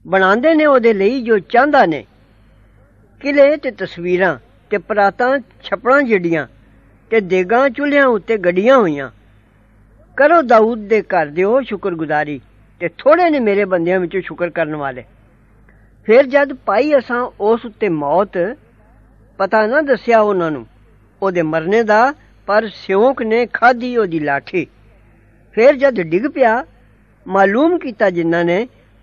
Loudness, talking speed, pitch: -15 LUFS, 135 wpm, 190 Hz